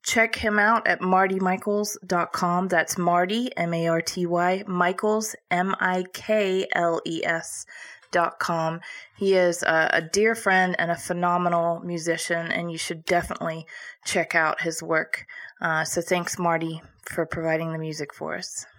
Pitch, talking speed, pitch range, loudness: 175 Hz, 120 wpm, 165-190 Hz, -24 LUFS